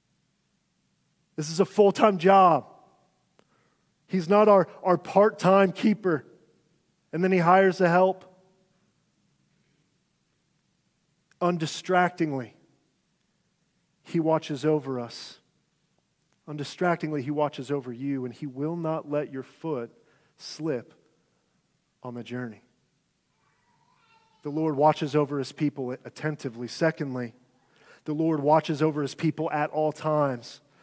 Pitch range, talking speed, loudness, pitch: 145-180 Hz, 110 wpm, -25 LUFS, 155 Hz